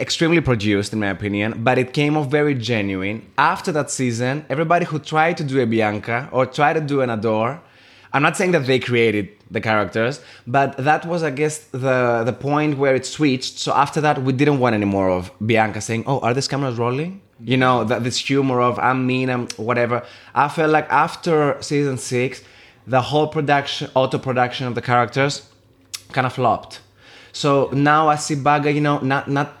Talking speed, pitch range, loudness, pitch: 195 wpm, 120-145 Hz, -19 LUFS, 130 Hz